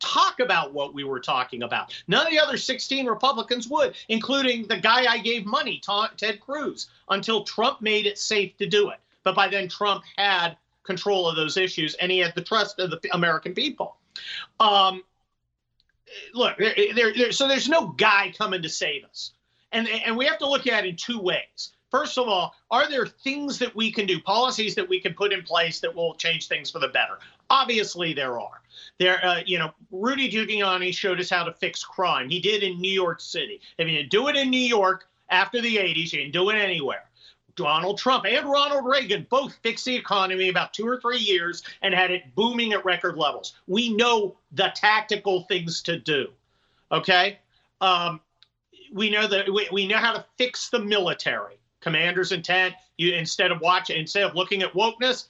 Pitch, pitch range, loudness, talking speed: 200 Hz, 180-235 Hz, -23 LUFS, 200 wpm